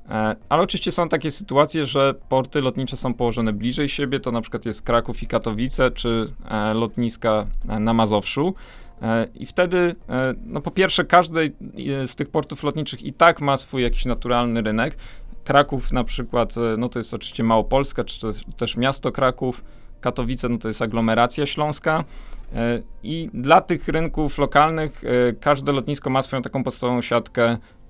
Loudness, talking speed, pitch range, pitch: -22 LUFS, 155 wpm, 115-145 Hz, 125 Hz